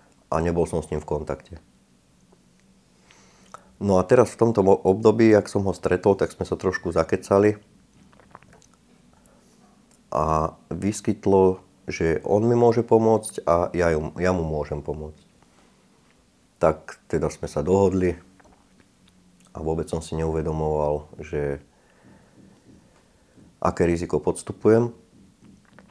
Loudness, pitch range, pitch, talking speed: -23 LUFS, 80-100 Hz, 90 Hz, 115 wpm